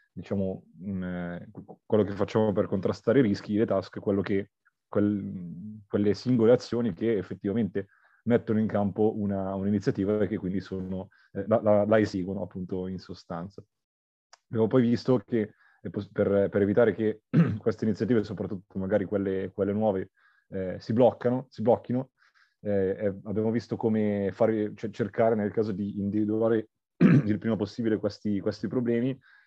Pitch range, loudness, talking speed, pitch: 100-115 Hz, -28 LUFS, 140 wpm, 105 Hz